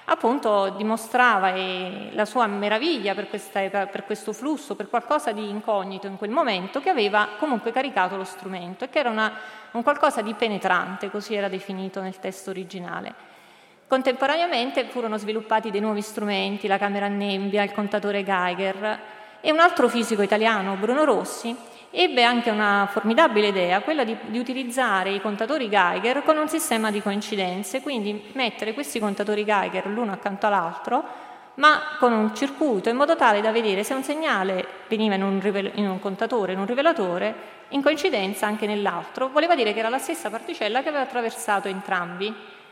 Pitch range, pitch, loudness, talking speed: 200-250 Hz, 215 Hz, -23 LUFS, 165 wpm